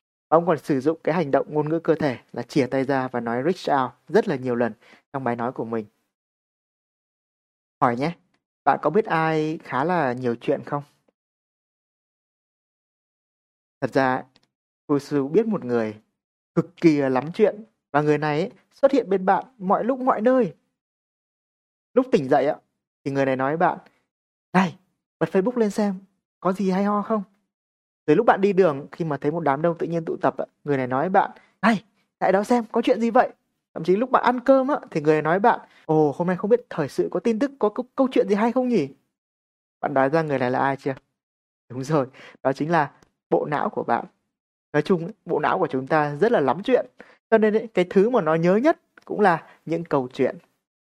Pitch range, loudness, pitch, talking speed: 140-215 Hz, -23 LUFS, 165 Hz, 210 wpm